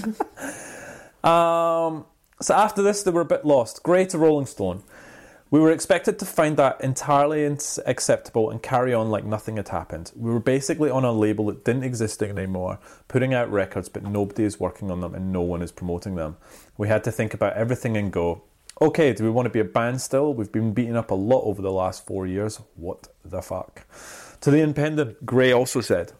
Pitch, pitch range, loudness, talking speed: 115 Hz, 100-145 Hz, -23 LUFS, 205 wpm